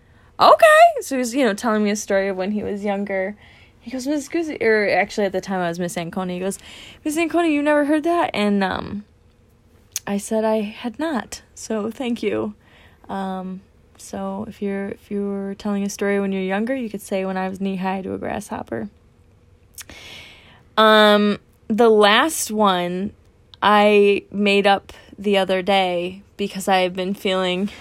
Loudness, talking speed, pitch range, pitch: -20 LUFS, 180 wpm, 190-220 Hz, 200 Hz